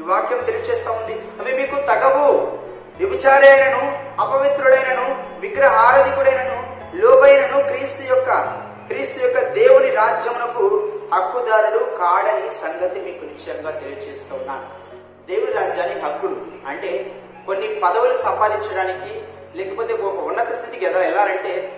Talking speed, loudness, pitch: 100 wpm, -17 LUFS, 275 Hz